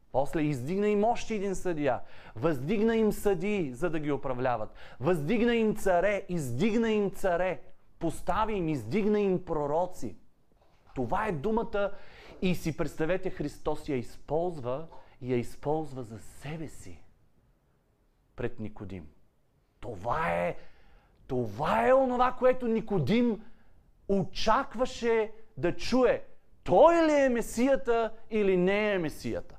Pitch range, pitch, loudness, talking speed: 140-220 Hz, 180 Hz, -29 LUFS, 120 wpm